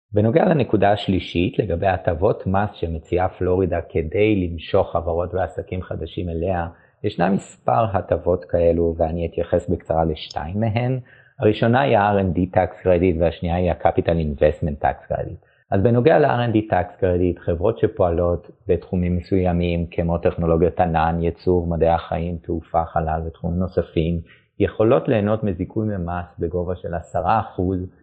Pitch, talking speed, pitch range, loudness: 90 Hz, 130 wpm, 85-100 Hz, -21 LUFS